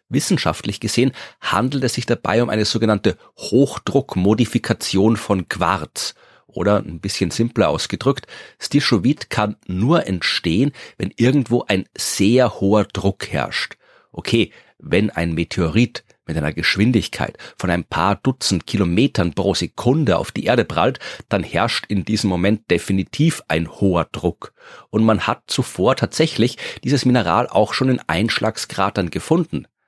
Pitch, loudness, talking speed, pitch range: 105 Hz, -19 LUFS, 135 wpm, 95-120 Hz